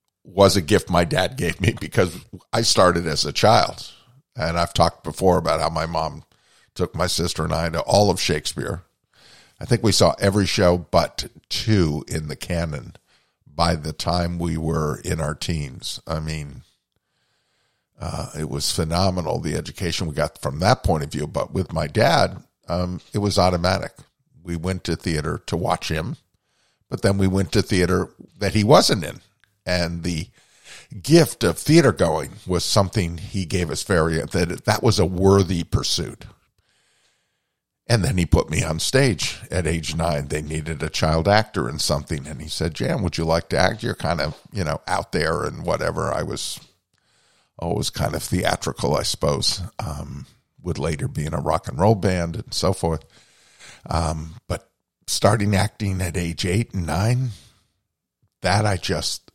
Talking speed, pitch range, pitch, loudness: 175 wpm, 80-100 Hz, 90 Hz, -22 LUFS